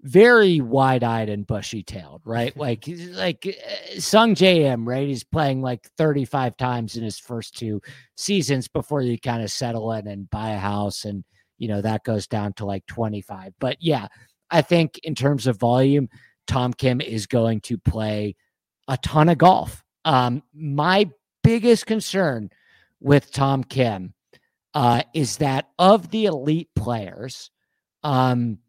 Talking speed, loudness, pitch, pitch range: 155 wpm, -21 LUFS, 130 Hz, 110-155 Hz